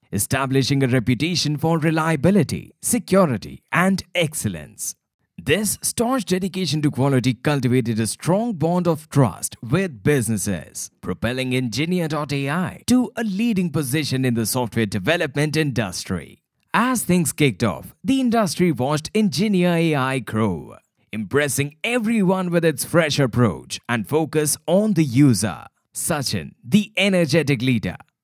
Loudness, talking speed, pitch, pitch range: -21 LUFS, 120 wpm, 150 Hz, 125-180 Hz